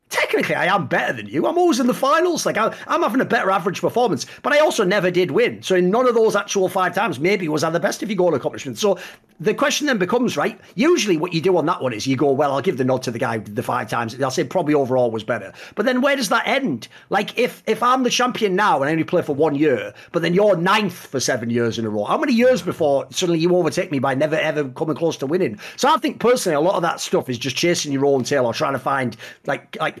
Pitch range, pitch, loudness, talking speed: 145-240 Hz, 180 Hz, -19 LUFS, 285 wpm